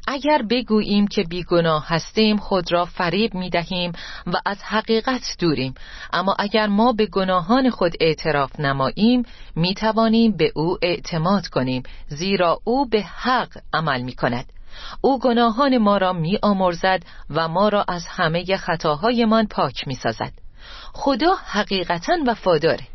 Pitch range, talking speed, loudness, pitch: 170-225 Hz, 140 wpm, -20 LUFS, 190 Hz